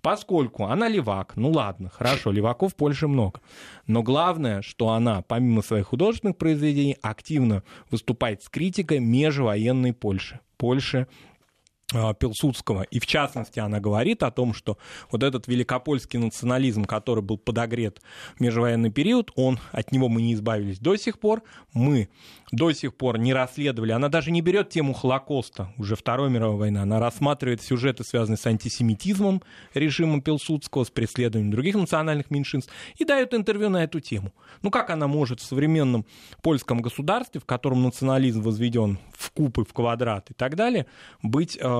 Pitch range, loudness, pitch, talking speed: 115-150 Hz, -25 LUFS, 125 Hz, 155 wpm